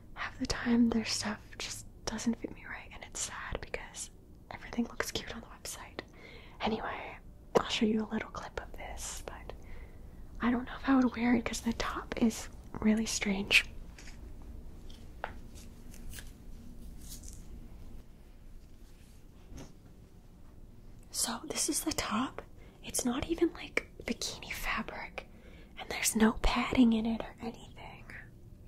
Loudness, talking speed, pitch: -33 LUFS, 130 wpm, 220 Hz